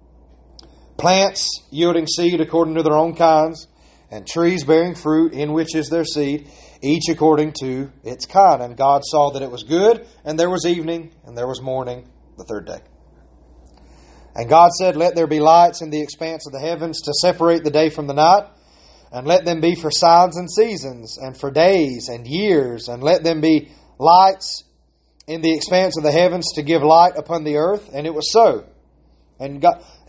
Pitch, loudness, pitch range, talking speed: 155 Hz, -17 LUFS, 130-170 Hz, 190 wpm